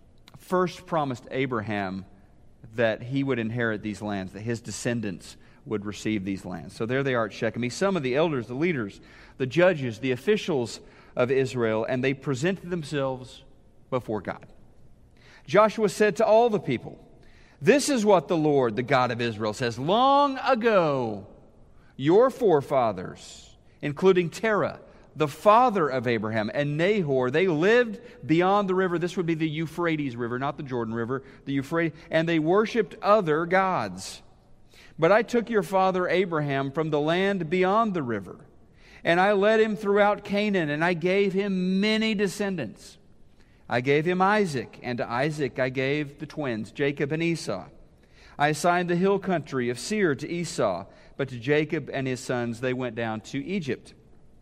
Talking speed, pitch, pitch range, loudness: 165 wpm, 145 Hz, 125-185 Hz, -25 LUFS